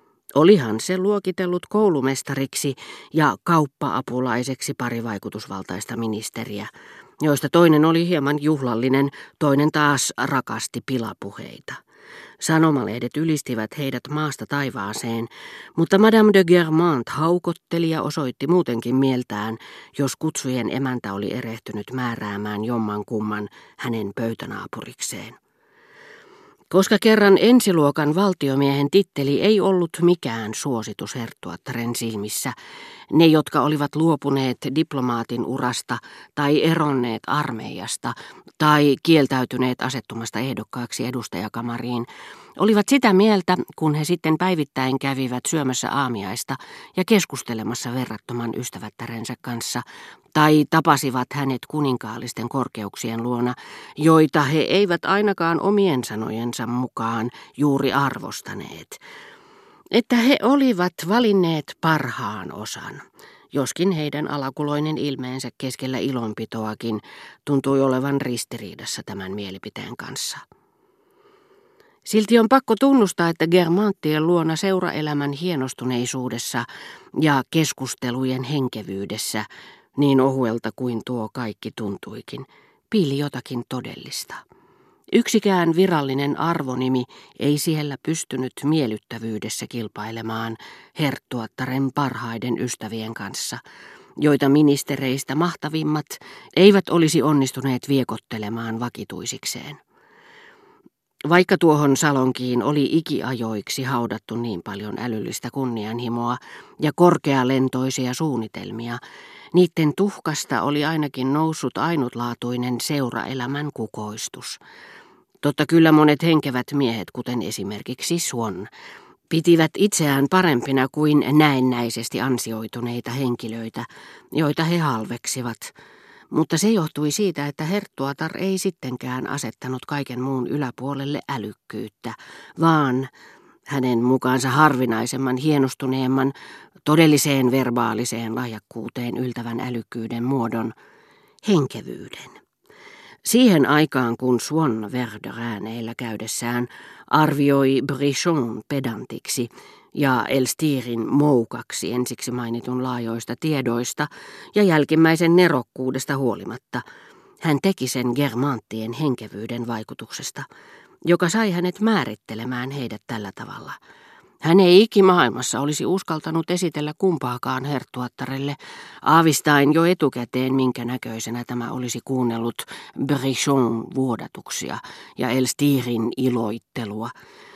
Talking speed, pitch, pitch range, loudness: 90 wpm, 135 Hz, 120-160 Hz, -21 LUFS